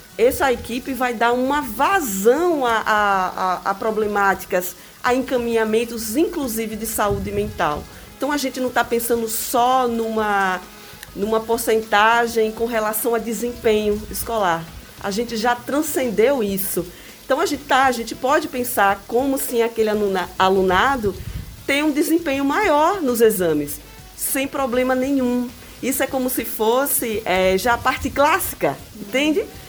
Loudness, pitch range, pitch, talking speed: -20 LUFS, 210-270 Hz, 235 Hz, 140 wpm